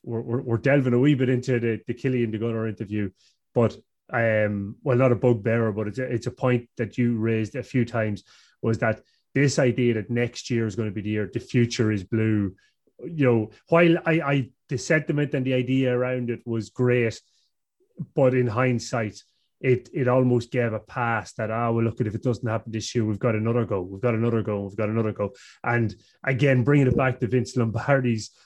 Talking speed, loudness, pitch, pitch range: 220 wpm, -24 LUFS, 120 Hz, 110-125 Hz